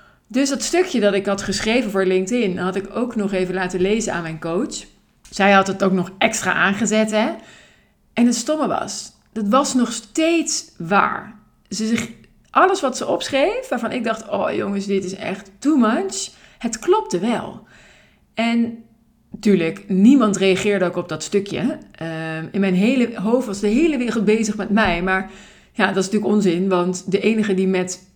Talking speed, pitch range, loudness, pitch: 185 wpm, 190-235 Hz, -19 LUFS, 210 Hz